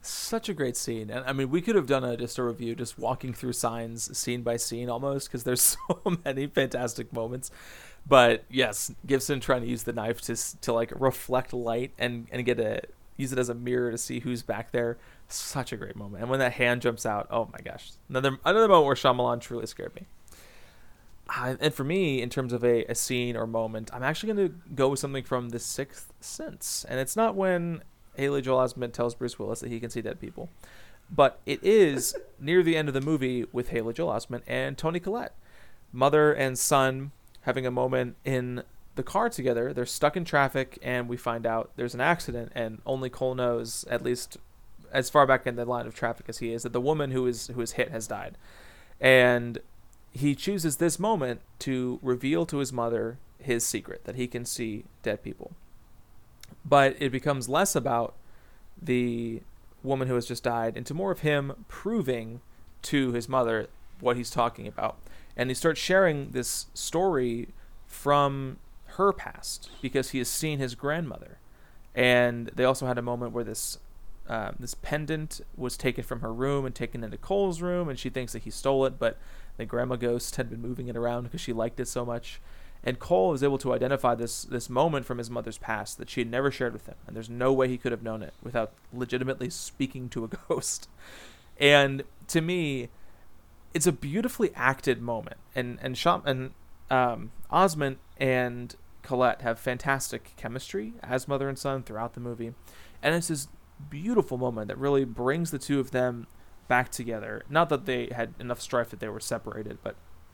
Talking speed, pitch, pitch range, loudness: 200 wpm, 125 Hz, 120-140 Hz, -28 LUFS